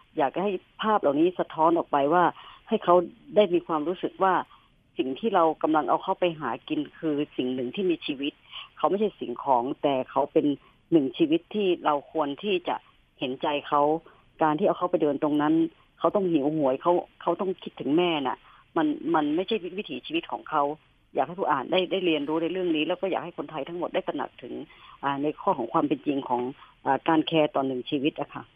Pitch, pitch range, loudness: 165 Hz, 150-200 Hz, -26 LUFS